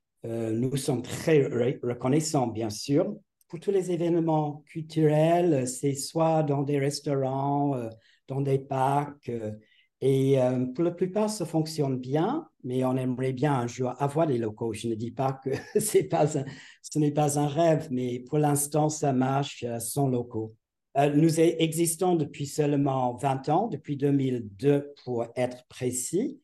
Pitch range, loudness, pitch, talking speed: 125-155 Hz, -27 LUFS, 140 Hz, 150 wpm